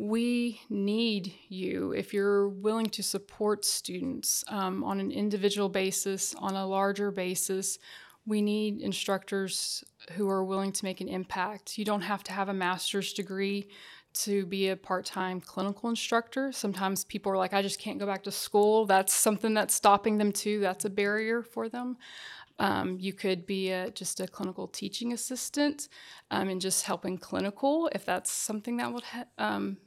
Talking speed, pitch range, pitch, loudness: 175 wpm, 190-215 Hz, 200 Hz, -30 LUFS